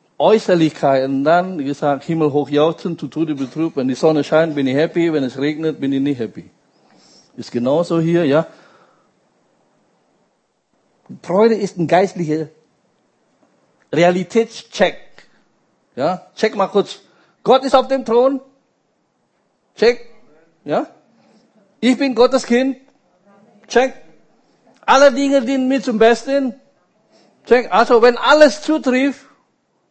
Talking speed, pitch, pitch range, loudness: 125 wpm, 195 Hz, 155-250 Hz, -16 LUFS